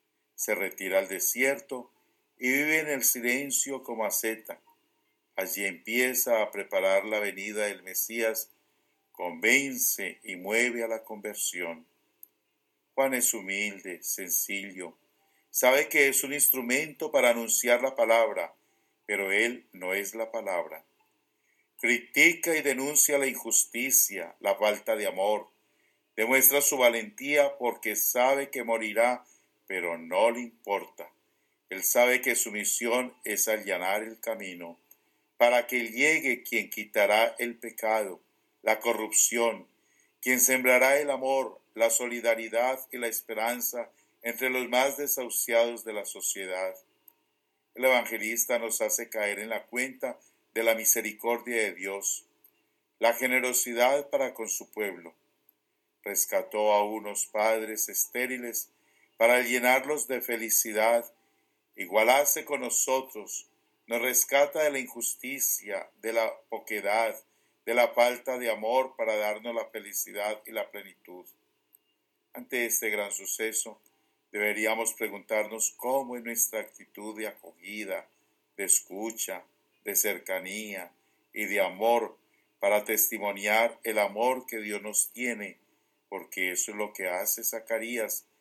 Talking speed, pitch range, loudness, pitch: 125 wpm, 105-125 Hz, -27 LUFS, 115 Hz